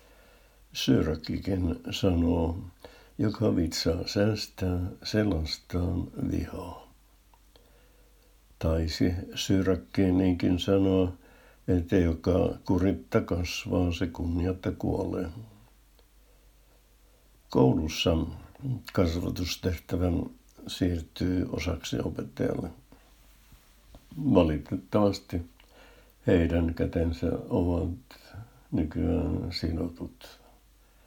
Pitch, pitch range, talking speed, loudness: 90 Hz, 85-95 Hz, 55 wpm, -29 LUFS